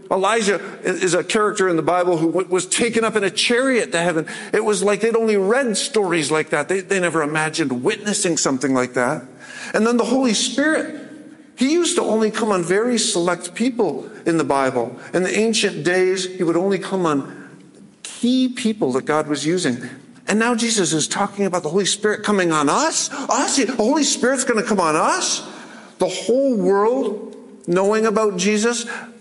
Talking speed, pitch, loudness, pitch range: 190 wpm, 205 Hz, -19 LUFS, 175-235 Hz